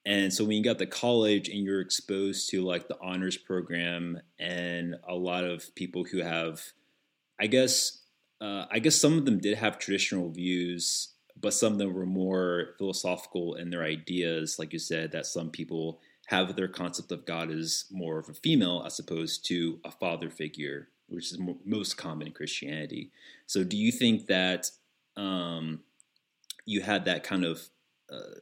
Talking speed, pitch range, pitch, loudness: 175 wpm, 85-100 Hz, 90 Hz, -30 LUFS